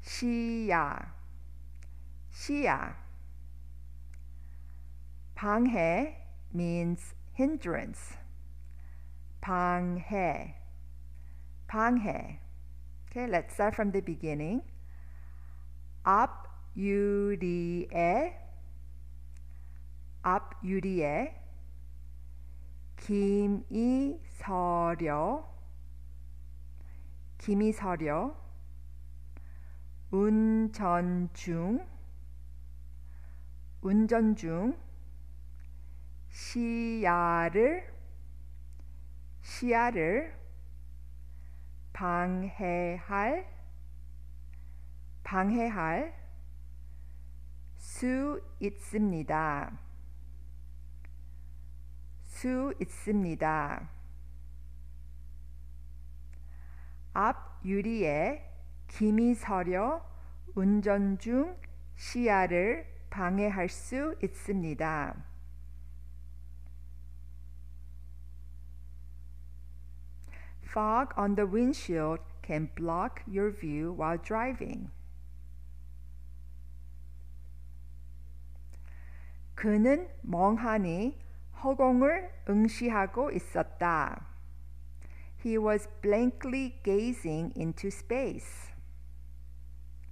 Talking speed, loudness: 45 wpm, -31 LUFS